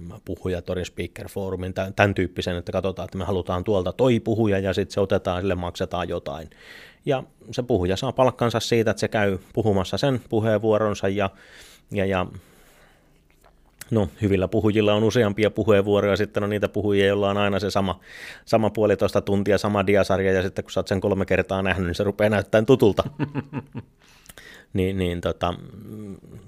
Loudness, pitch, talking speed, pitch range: -23 LUFS, 100 Hz, 160 wpm, 95-110 Hz